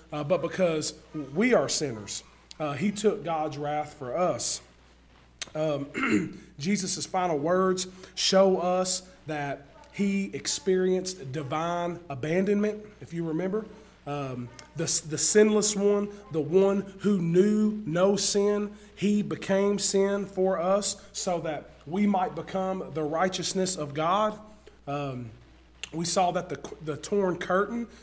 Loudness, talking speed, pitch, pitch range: -27 LUFS, 130 wpm, 180 Hz, 155-200 Hz